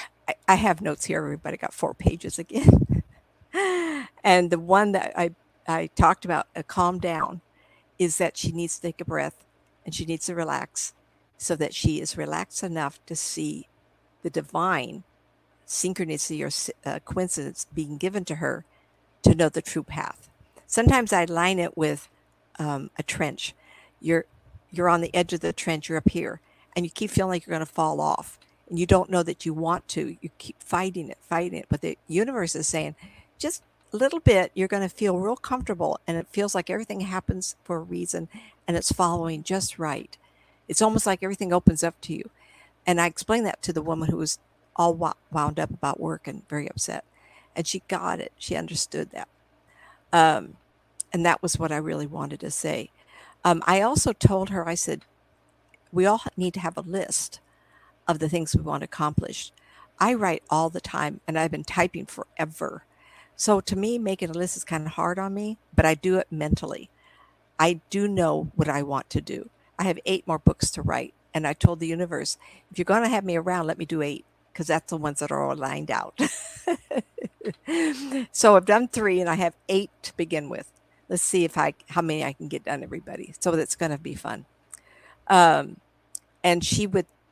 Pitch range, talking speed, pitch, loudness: 160-190 Hz, 195 wpm, 175 Hz, -25 LUFS